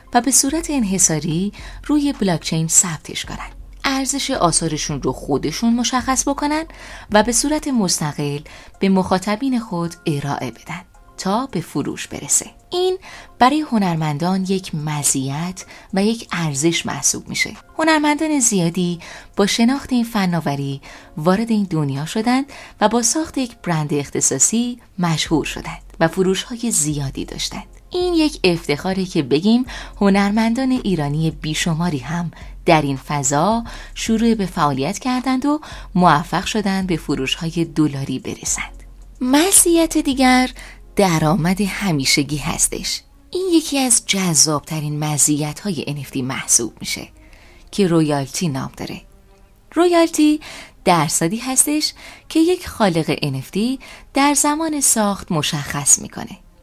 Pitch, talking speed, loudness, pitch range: 190 Hz, 120 wpm, -18 LUFS, 155-255 Hz